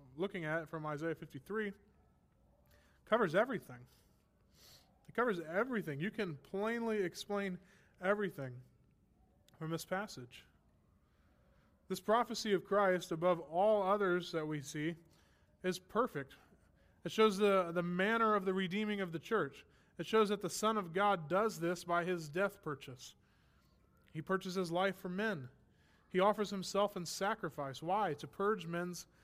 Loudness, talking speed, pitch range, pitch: -37 LUFS, 140 wpm, 155-200 Hz, 180 Hz